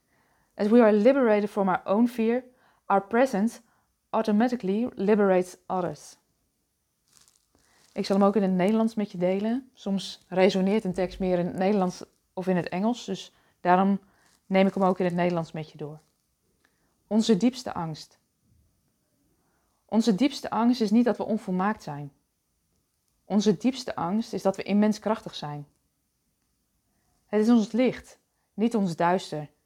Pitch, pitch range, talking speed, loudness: 195 Hz, 175-220 Hz, 150 wpm, -25 LUFS